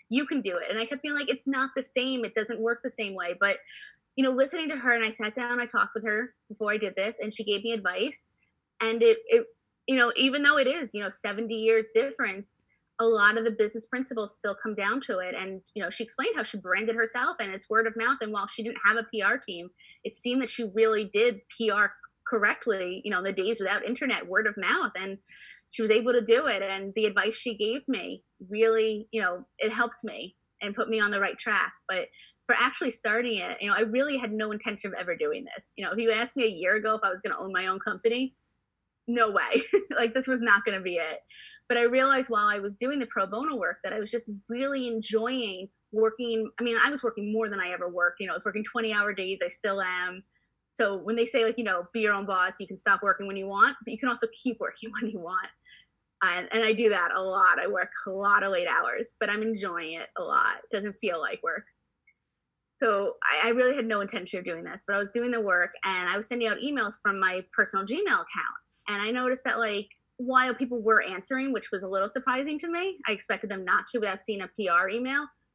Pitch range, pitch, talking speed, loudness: 205-245 Hz, 225 Hz, 255 wpm, -27 LUFS